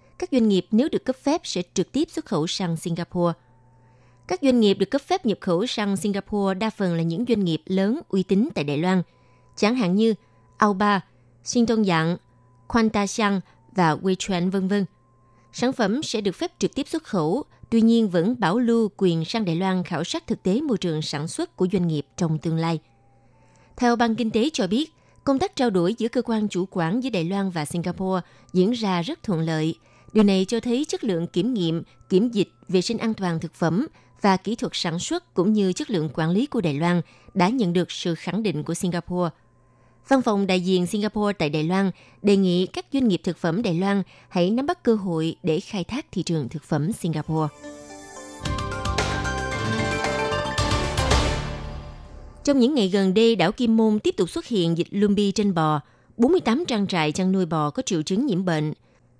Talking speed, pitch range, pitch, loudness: 205 wpm, 160-220 Hz, 185 Hz, -23 LUFS